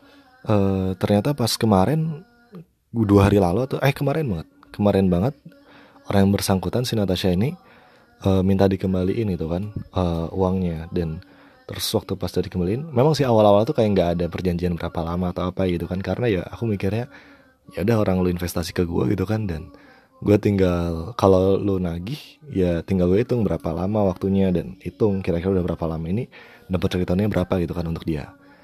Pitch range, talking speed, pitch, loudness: 90-110 Hz, 180 wpm, 95 Hz, -22 LUFS